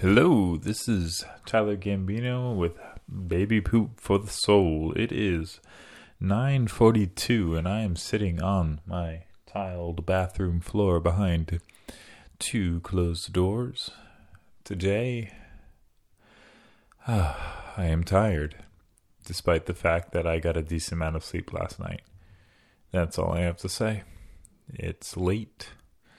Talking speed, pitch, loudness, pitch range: 120 wpm, 95 Hz, -27 LUFS, 85-105 Hz